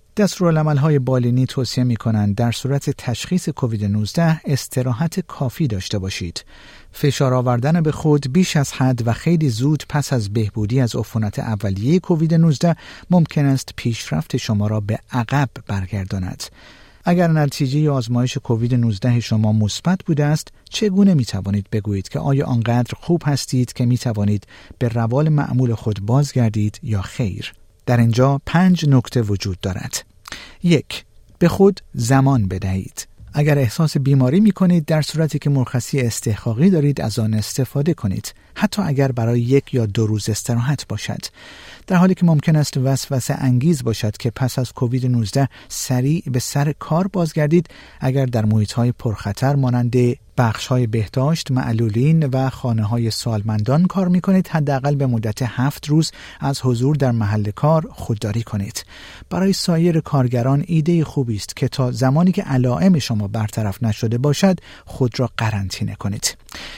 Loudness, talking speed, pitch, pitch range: -19 LUFS, 155 wpm, 130 Hz, 115-150 Hz